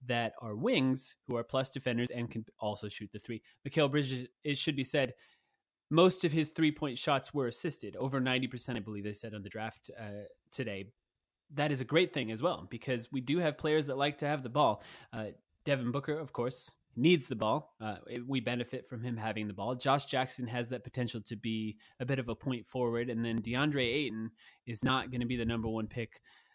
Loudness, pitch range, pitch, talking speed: -34 LUFS, 115-140 Hz, 125 Hz, 220 wpm